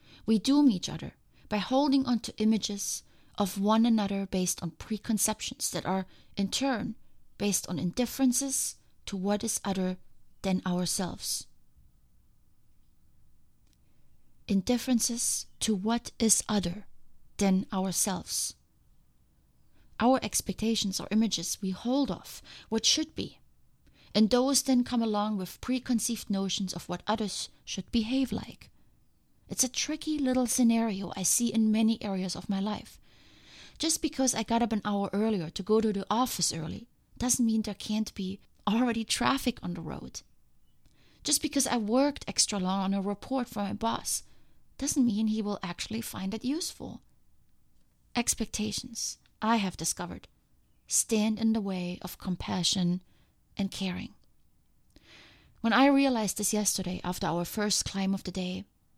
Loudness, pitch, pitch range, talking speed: -29 LUFS, 210 Hz, 190-235 Hz, 140 wpm